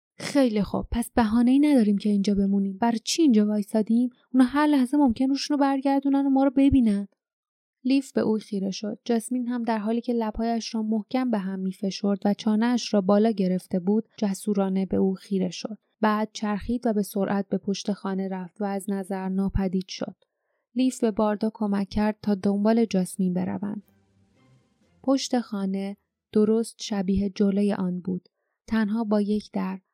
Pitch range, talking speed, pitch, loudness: 195-240 Hz, 170 wpm, 210 Hz, -25 LUFS